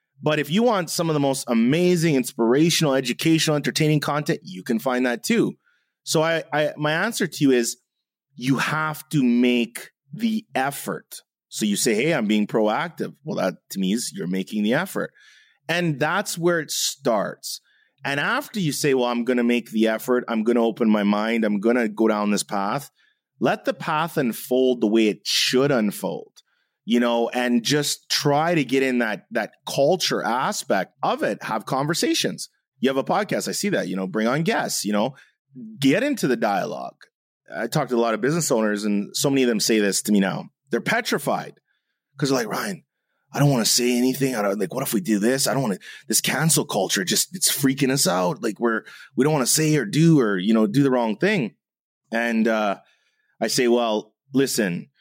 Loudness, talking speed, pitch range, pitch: -22 LUFS, 210 wpm, 115-155 Hz, 130 Hz